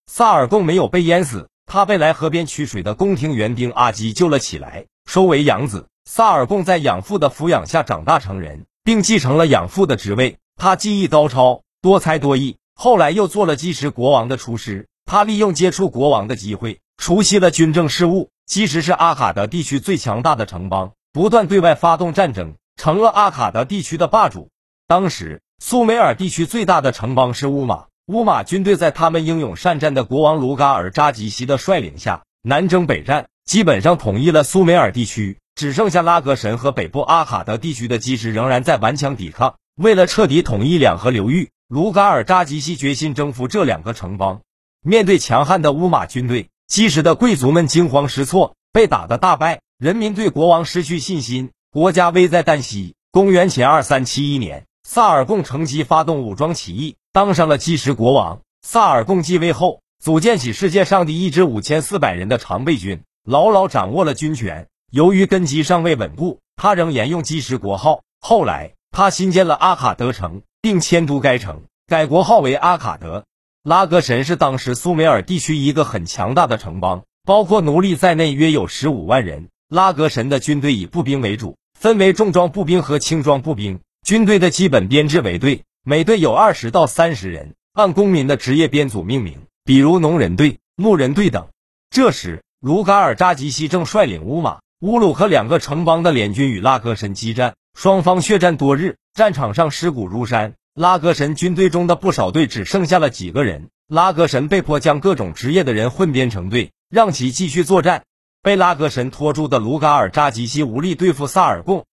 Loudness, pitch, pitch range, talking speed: -16 LUFS, 155 Hz, 130-185 Hz, 295 characters per minute